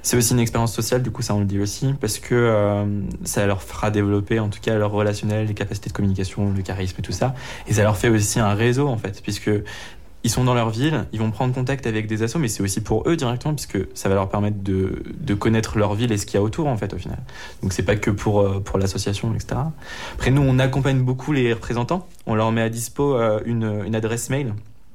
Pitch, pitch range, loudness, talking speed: 110 Hz, 100-125 Hz, -22 LUFS, 255 wpm